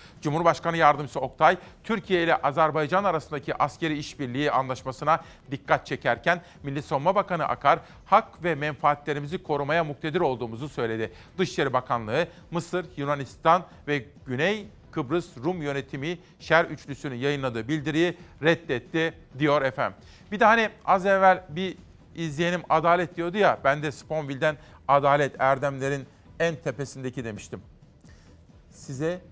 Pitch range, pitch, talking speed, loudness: 140-170 Hz, 155 Hz, 120 wpm, -26 LUFS